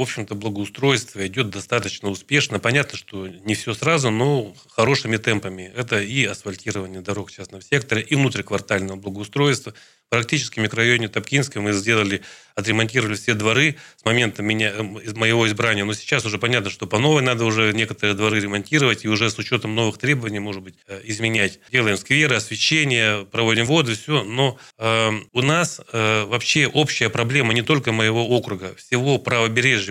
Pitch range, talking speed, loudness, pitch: 105-125 Hz, 155 wpm, -20 LUFS, 110 Hz